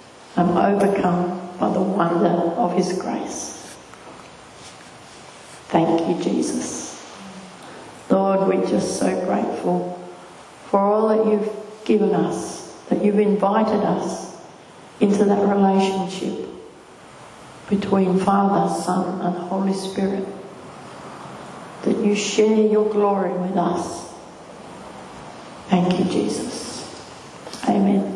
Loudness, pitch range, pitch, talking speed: -21 LUFS, 180-205 Hz, 195 Hz, 100 wpm